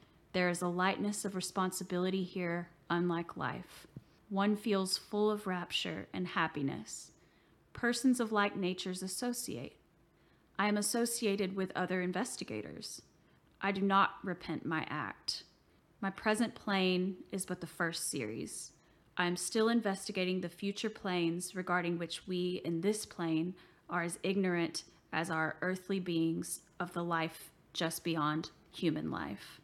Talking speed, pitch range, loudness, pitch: 140 wpm, 170-200 Hz, -36 LUFS, 185 Hz